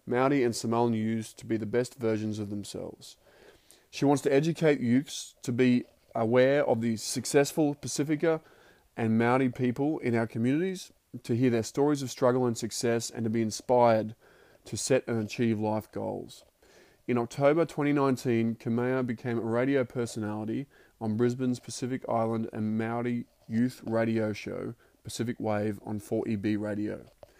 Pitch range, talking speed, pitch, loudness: 110-130 Hz, 150 wpm, 120 Hz, -29 LUFS